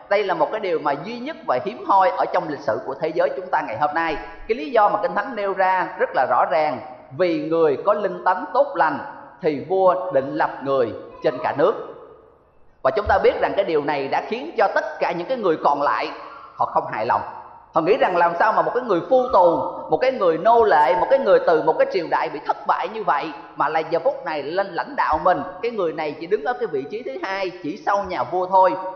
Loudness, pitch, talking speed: -21 LUFS, 200 Hz, 260 wpm